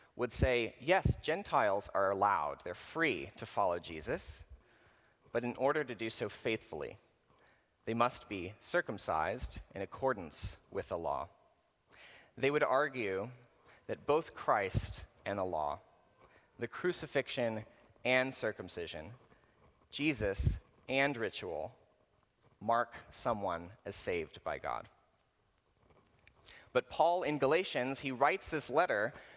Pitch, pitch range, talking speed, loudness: 120 Hz, 110-135 Hz, 115 wpm, -36 LUFS